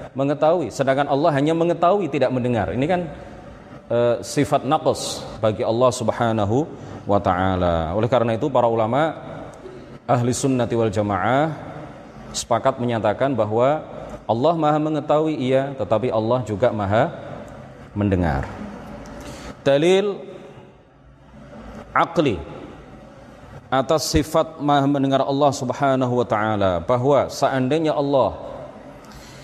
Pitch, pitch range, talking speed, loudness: 130 Hz, 115-145 Hz, 105 wpm, -20 LUFS